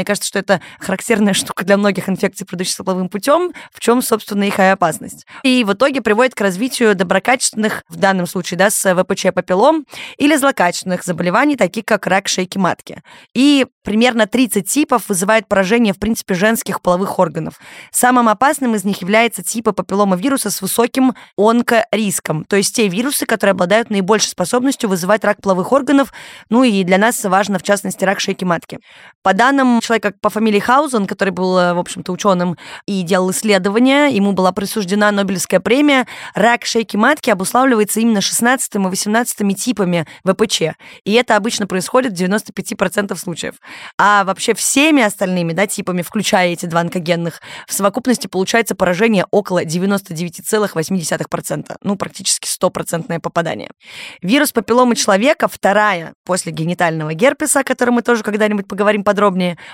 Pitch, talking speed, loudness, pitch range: 205 Hz, 155 wpm, -15 LUFS, 185-230 Hz